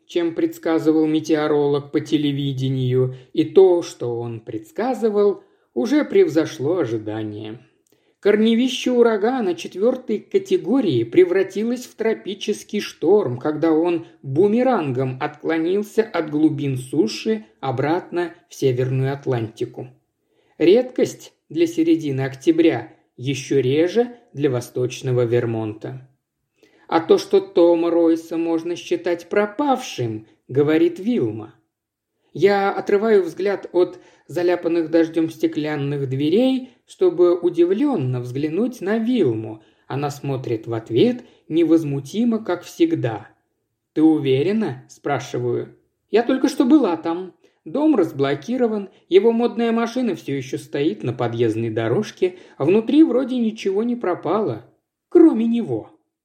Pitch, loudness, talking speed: 175 Hz, -20 LUFS, 105 wpm